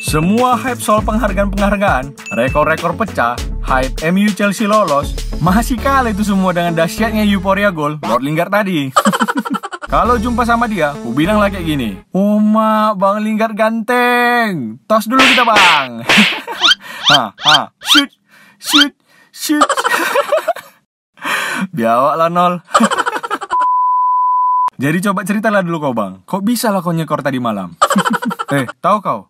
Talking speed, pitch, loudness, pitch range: 125 wpm, 215 Hz, -13 LUFS, 180-250 Hz